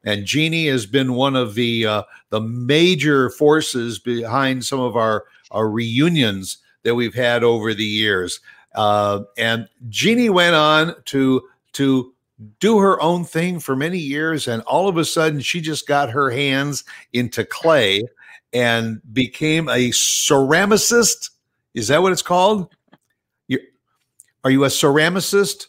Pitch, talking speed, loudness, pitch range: 135 Hz, 145 wpm, -18 LUFS, 115-160 Hz